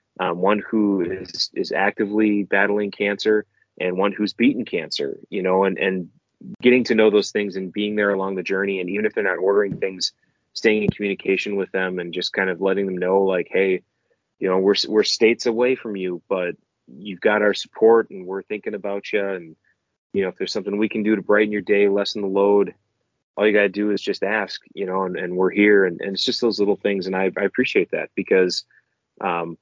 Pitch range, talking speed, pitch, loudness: 95-105 Hz, 225 wpm, 100 Hz, -21 LUFS